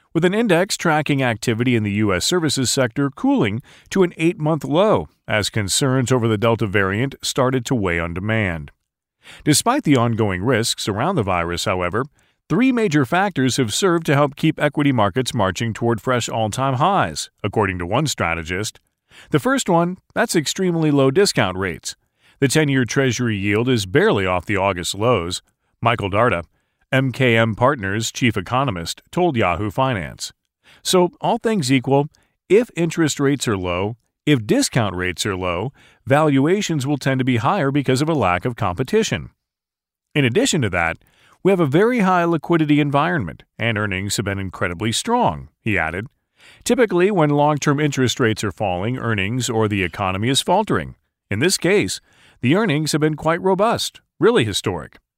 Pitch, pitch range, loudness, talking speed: 130 Hz, 105-155 Hz, -19 LUFS, 165 wpm